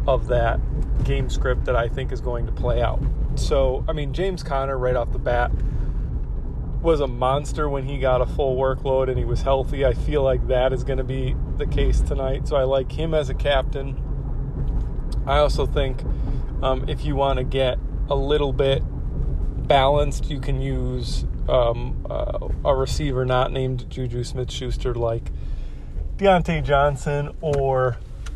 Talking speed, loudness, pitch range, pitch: 170 wpm, -23 LUFS, 120-140 Hz, 130 Hz